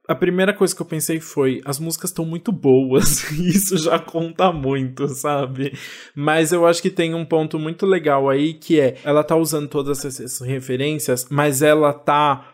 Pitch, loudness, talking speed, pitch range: 155 Hz, -19 LUFS, 185 wpm, 140-165 Hz